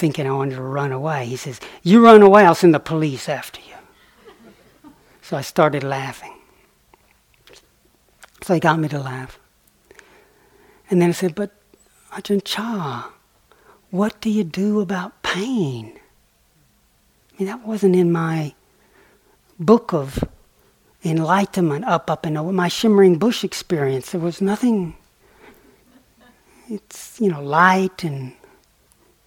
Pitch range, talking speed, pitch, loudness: 150-205 Hz, 135 wpm, 175 Hz, -18 LUFS